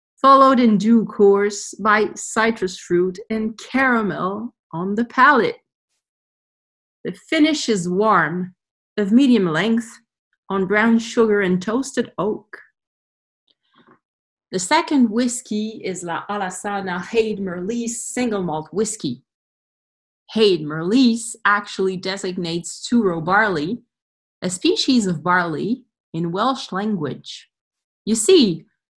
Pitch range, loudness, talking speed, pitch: 185-235 Hz, -19 LUFS, 105 wpm, 210 Hz